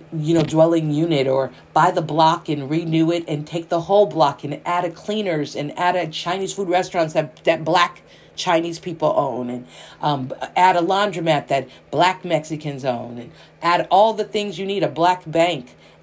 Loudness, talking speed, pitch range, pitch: -20 LUFS, 190 wpm, 150-180 Hz, 165 Hz